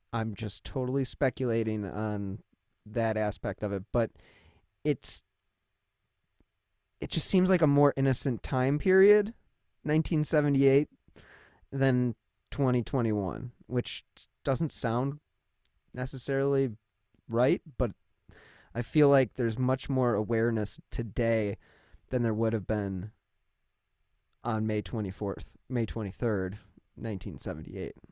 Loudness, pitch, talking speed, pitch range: -30 LUFS, 115 Hz, 100 wpm, 105-135 Hz